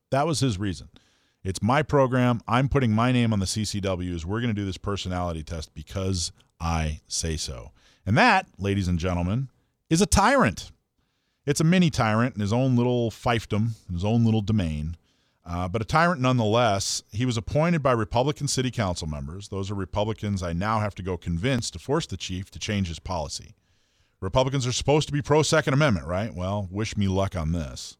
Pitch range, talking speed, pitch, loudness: 90-125 Hz, 195 wpm, 105 Hz, -25 LUFS